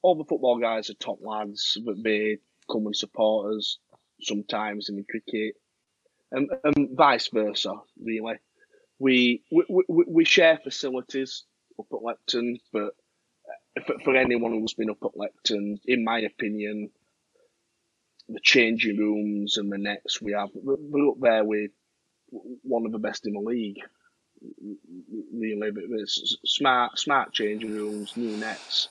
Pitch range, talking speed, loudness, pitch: 105-135 Hz, 145 wpm, -25 LUFS, 110 Hz